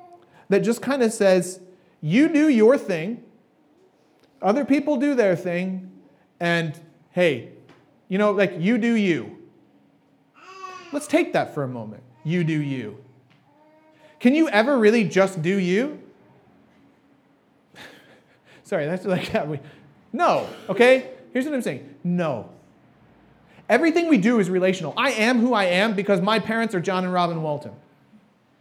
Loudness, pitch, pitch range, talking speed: -21 LUFS, 200 Hz, 175-255 Hz, 145 wpm